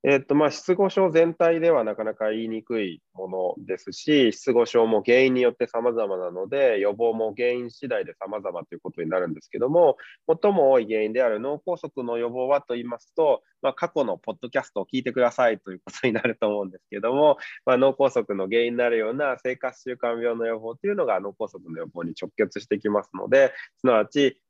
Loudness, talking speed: -24 LUFS, 420 characters per minute